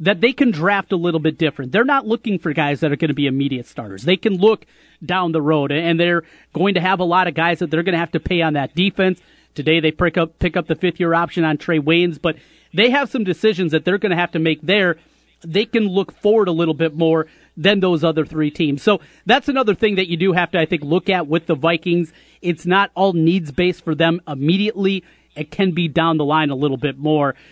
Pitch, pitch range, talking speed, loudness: 170 Hz, 160-190 Hz, 255 wpm, -18 LUFS